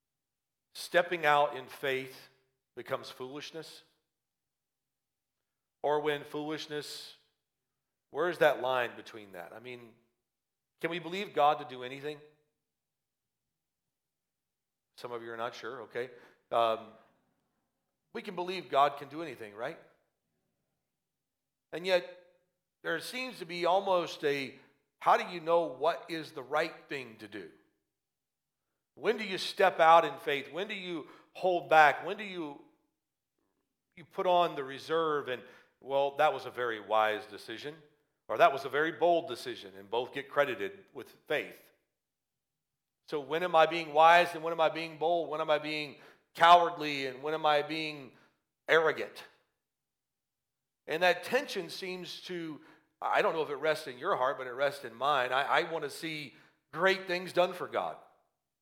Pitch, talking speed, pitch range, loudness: 155 Hz, 155 wpm, 135-175 Hz, -31 LUFS